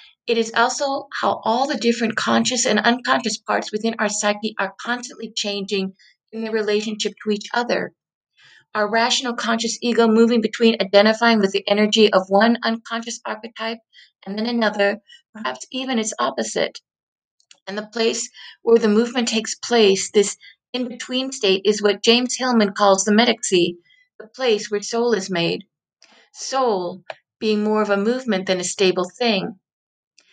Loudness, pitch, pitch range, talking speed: -20 LUFS, 220 Hz, 205-235 Hz, 155 wpm